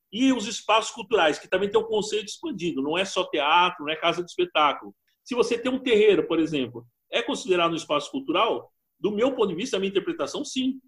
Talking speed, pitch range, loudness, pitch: 225 wpm, 170-255 Hz, -24 LUFS, 210 Hz